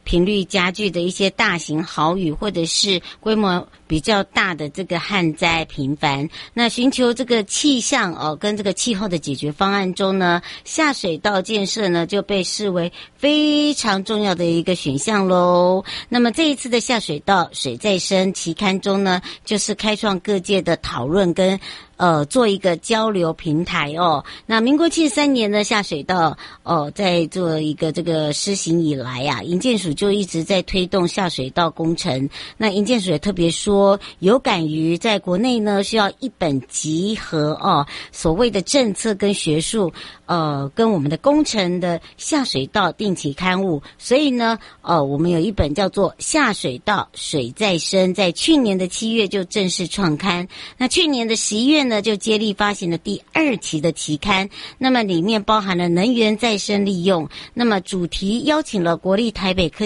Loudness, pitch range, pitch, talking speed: -19 LUFS, 170-215 Hz, 190 Hz, 260 characters per minute